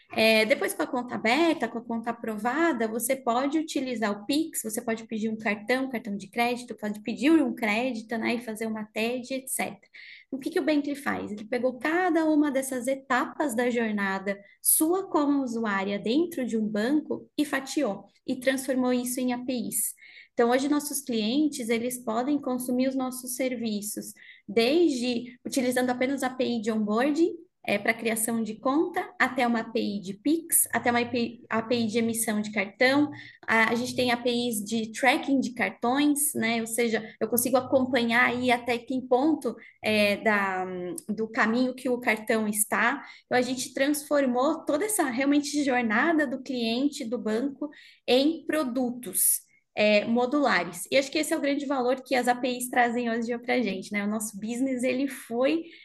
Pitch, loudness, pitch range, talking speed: 250 Hz, -26 LUFS, 225-275 Hz, 175 wpm